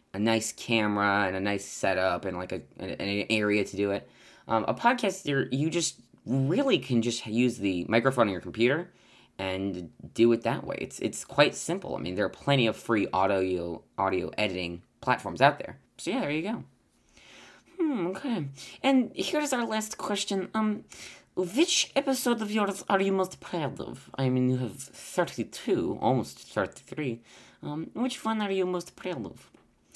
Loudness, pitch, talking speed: -28 LUFS, 125 Hz, 175 wpm